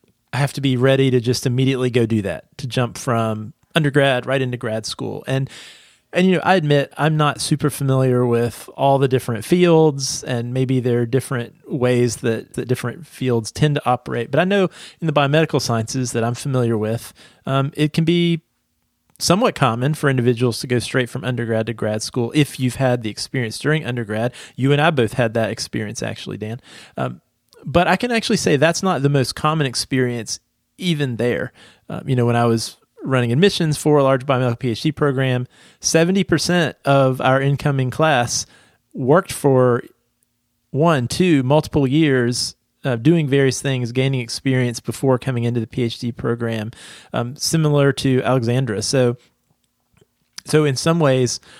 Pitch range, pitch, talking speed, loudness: 120-145 Hz, 130 Hz, 175 wpm, -19 LUFS